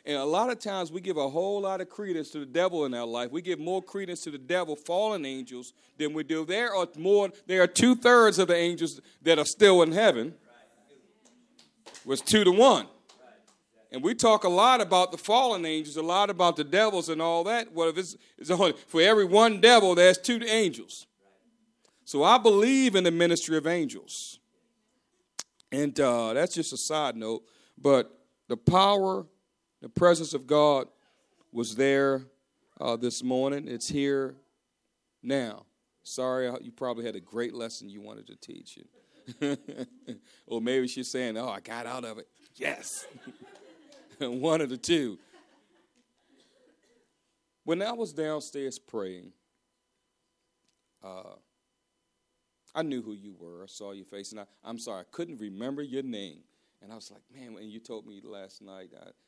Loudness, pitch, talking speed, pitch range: -26 LUFS, 155 Hz, 170 wpm, 125-190 Hz